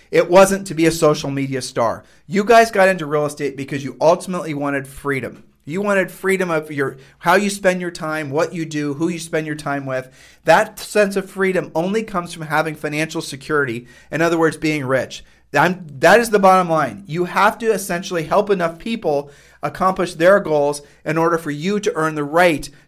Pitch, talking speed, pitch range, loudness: 160 Hz, 200 wpm, 145-185 Hz, -18 LUFS